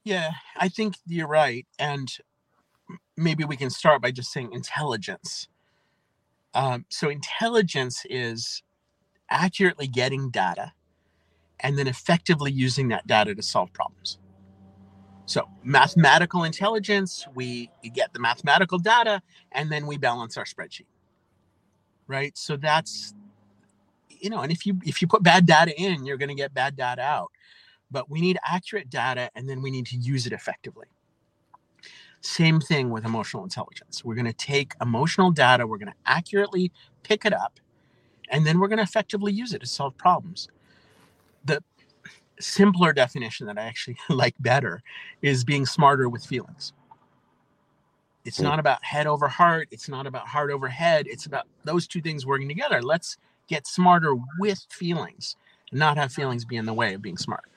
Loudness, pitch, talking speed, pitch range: -24 LUFS, 140 Hz, 160 wpm, 125-175 Hz